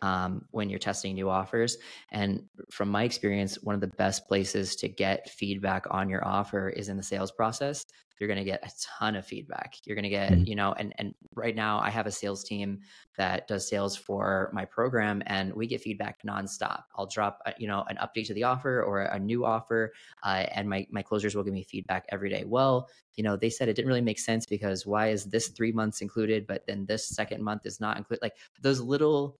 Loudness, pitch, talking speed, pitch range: -31 LUFS, 105 Hz, 225 wpm, 100-110 Hz